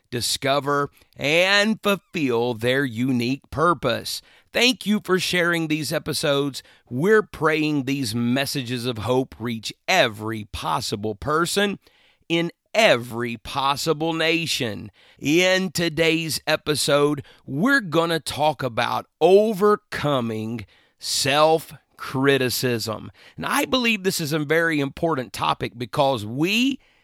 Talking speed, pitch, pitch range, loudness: 105 wpm, 150 Hz, 125-170 Hz, -22 LUFS